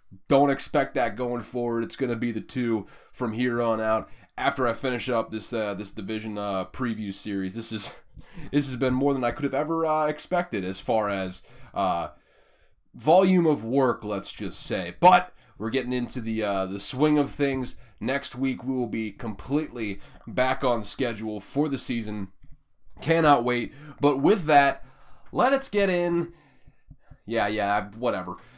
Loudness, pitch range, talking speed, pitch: -25 LUFS, 110-140 Hz, 170 wpm, 120 Hz